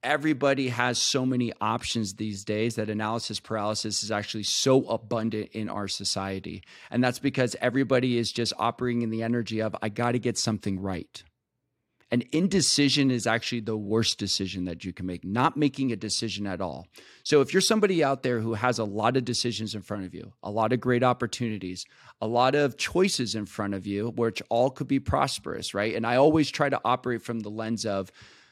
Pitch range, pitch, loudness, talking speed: 105-125 Hz, 115 Hz, -27 LUFS, 200 wpm